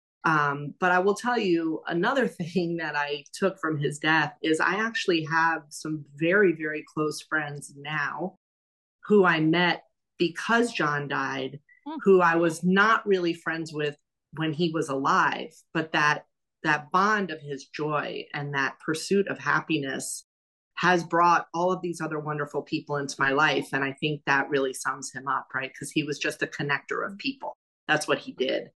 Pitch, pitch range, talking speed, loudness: 155 Hz, 145-175 Hz, 175 wpm, -26 LUFS